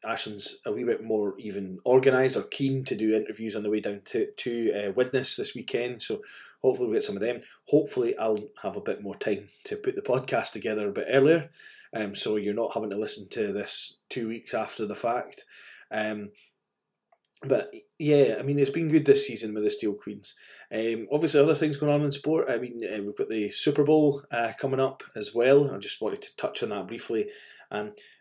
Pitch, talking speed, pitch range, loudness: 135 Hz, 215 wpm, 110-160 Hz, -27 LUFS